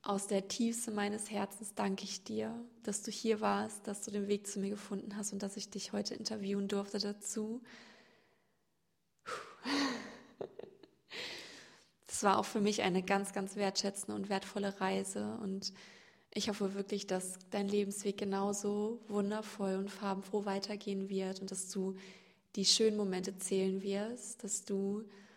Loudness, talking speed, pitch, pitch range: -37 LUFS, 150 wpm, 205 Hz, 195-215 Hz